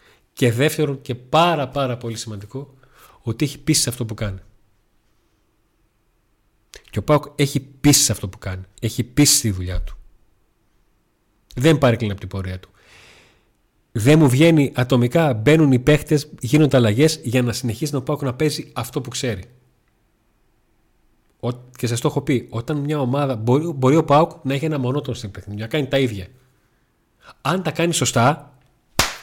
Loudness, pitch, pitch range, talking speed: -19 LUFS, 125 Hz, 110-145 Hz, 160 wpm